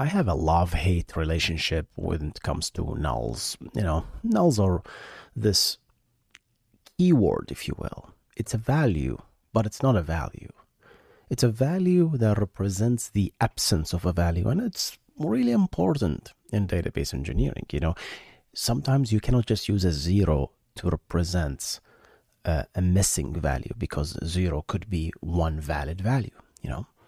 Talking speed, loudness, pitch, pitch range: 150 wpm, -26 LUFS, 95 Hz, 80-115 Hz